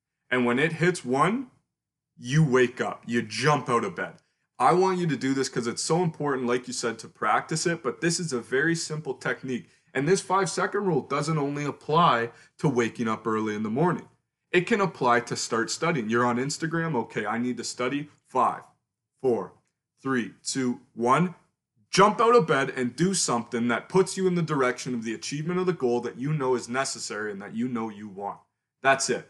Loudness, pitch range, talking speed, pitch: -26 LUFS, 120-170 Hz, 210 wpm, 135 Hz